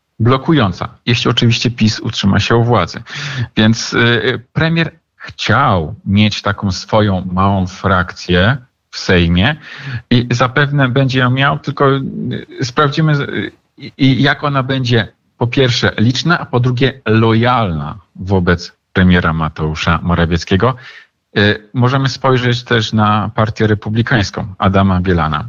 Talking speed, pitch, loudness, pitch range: 110 wpm, 115 Hz, -14 LUFS, 95-130 Hz